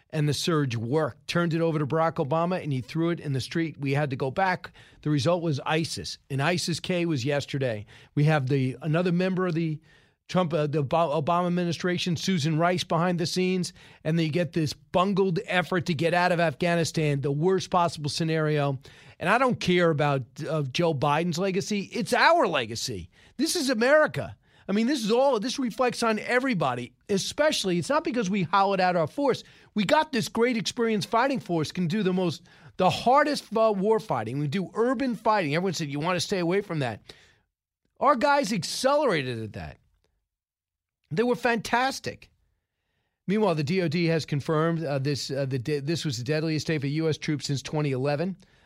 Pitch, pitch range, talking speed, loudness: 170 Hz, 145-195 Hz, 185 wpm, -26 LUFS